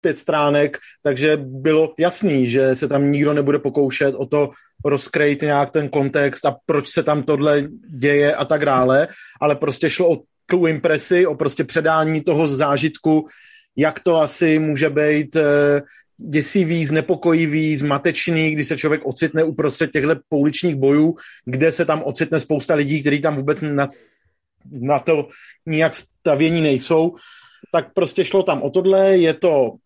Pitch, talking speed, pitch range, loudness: 155 Hz, 155 wpm, 145-160 Hz, -18 LUFS